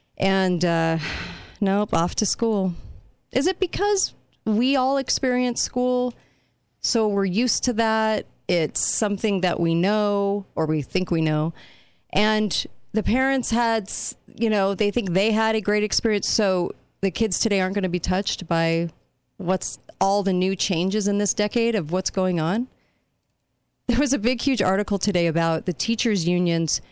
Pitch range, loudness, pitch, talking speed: 180-225 Hz, -23 LUFS, 200 Hz, 165 wpm